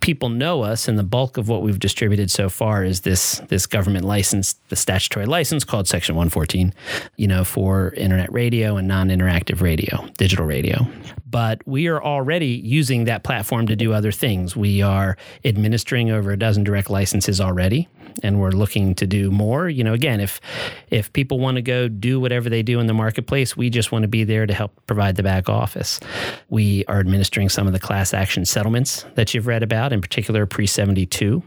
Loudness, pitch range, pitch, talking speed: -20 LUFS, 95-120 Hz, 105 Hz, 205 wpm